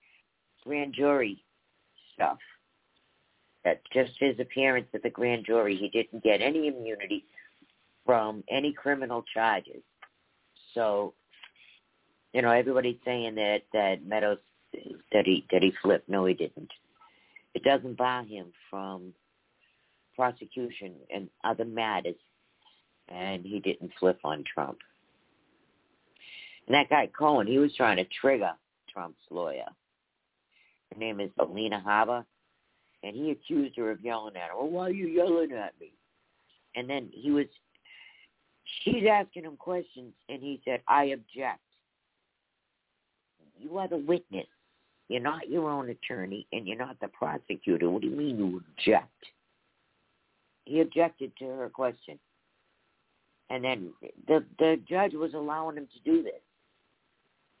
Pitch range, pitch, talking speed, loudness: 110-150 Hz, 125 Hz, 135 wpm, -29 LUFS